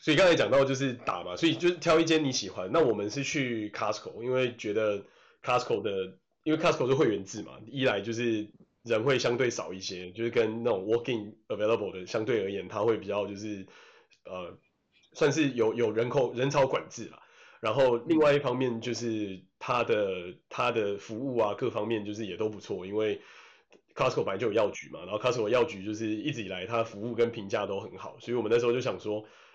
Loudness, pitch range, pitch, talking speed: -29 LUFS, 105-135 Hz, 115 Hz, 375 characters per minute